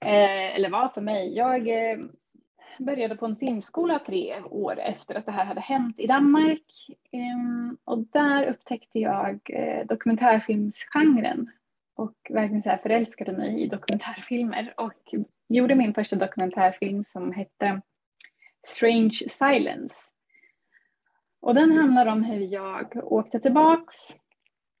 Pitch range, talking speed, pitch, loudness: 210-270 Hz, 115 wpm, 235 Hz, -25 LUFS